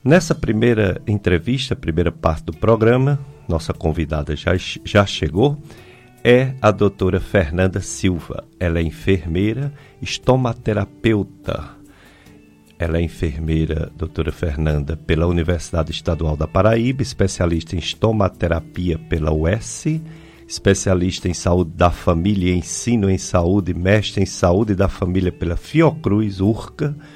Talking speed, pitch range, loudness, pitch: 115 wpm, 85-110 Hz, -19 LUFS, 95 Hz